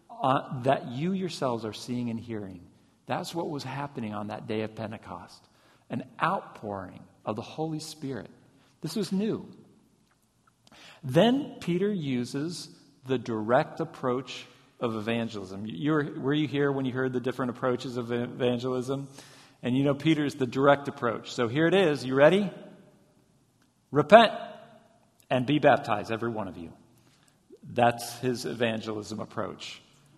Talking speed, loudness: 145 wpm, -28 LUFS